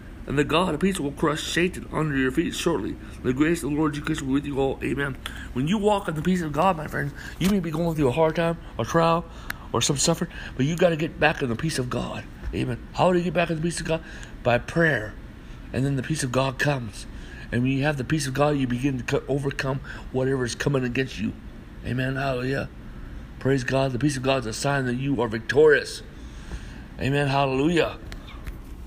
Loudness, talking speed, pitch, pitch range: -25 LUFS, 235 wpm, 140 Hz, 130-160 Hz